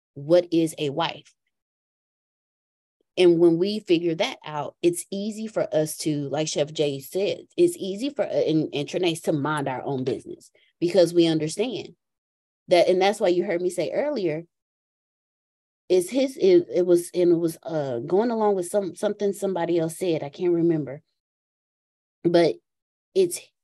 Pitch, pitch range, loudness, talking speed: 175 Hz, 155-195 Hz, -24 LUFS, 165 wpm